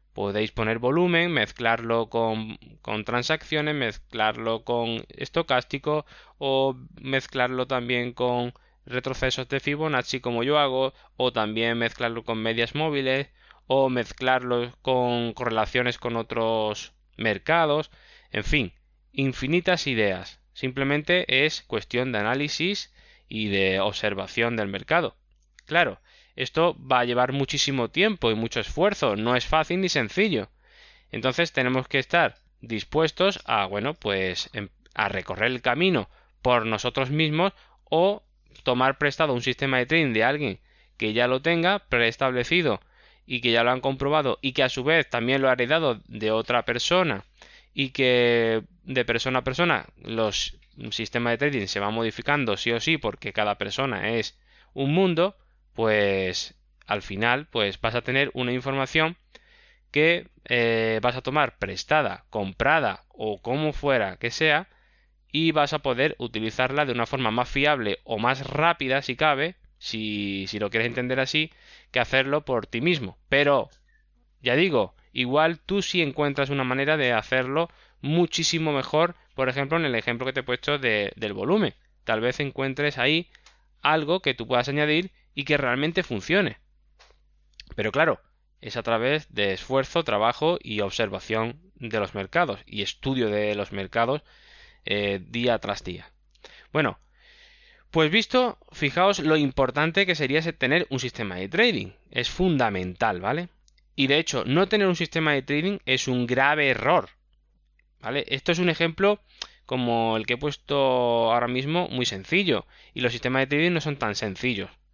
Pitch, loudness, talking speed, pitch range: 130 Hz, -25 LUFS, 150 wpm, 115-150 Hz